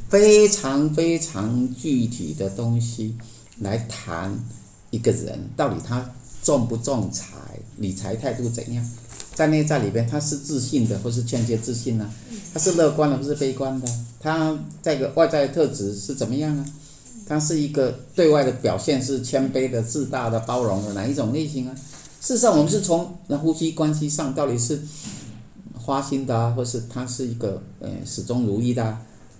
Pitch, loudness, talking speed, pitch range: 130 Hz, -23 LUFS, 255 characters per minute, 115-150 Hz